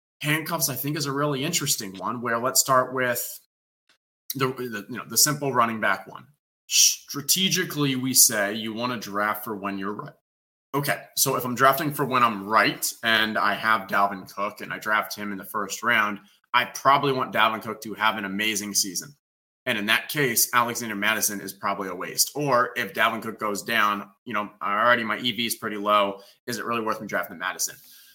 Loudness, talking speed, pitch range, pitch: -23 LUFS, 205 wpm, 105-135 Hz, 115 Hz